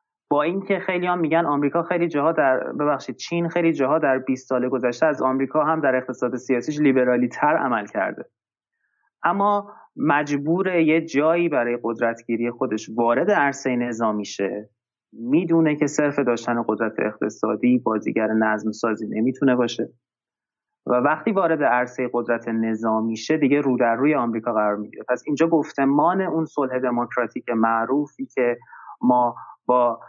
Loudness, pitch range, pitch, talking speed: -22 LUFS, 120-155 Hz, 130 Hz, 145 wpm